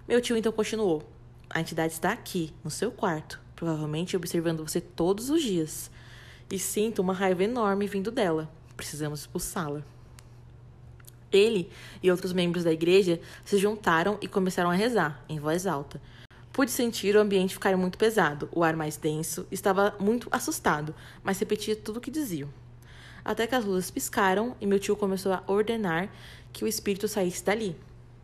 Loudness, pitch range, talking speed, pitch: -28 LUFS, 155-205 Hz, 165 wpm, 185 Hz